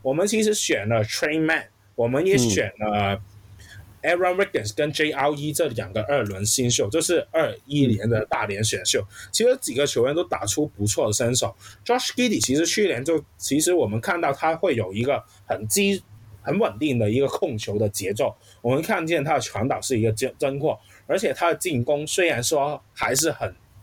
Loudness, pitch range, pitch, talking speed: -23 LUFS, 105-160 Hz, 130 Hz, 325 characters per minute